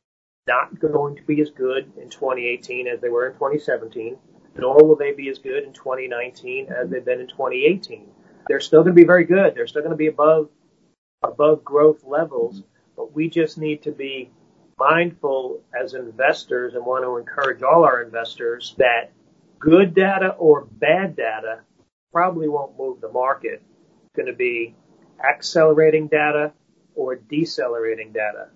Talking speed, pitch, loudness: 165 wpm, 160 Hz, -19 LUFS